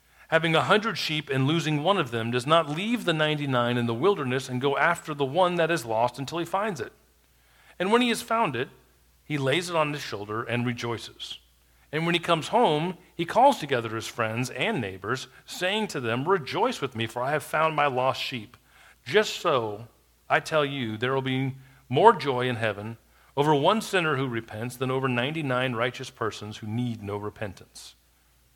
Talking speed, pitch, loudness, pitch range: 200 wpm, 135 Hz, -26 LUFS, 115-170 Hz